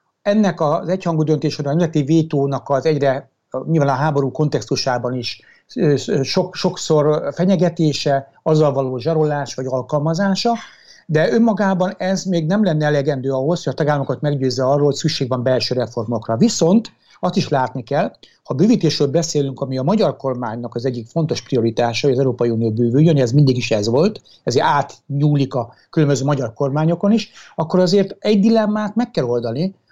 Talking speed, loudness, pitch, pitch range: 160 wpm, -18 LUFS, 150 Hz, 130-175 Hz